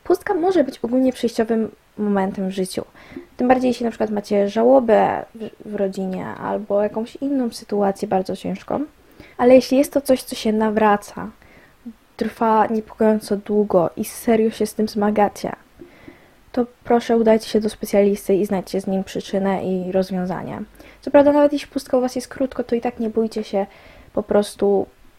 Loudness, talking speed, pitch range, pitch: -20 LUFS, 165 wpm, 200-245 Hz, 220 Hz